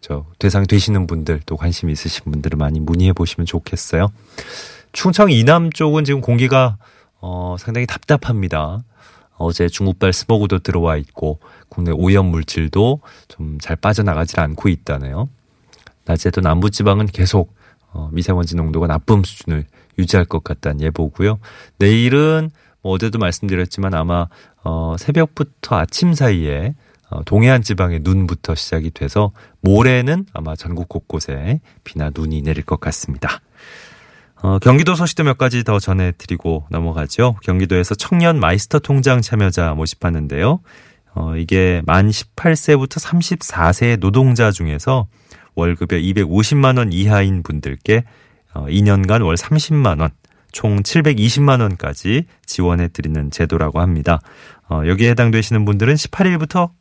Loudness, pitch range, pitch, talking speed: -16 LUFS, 80-120 Hz, 95 Hz, 300 characters per minute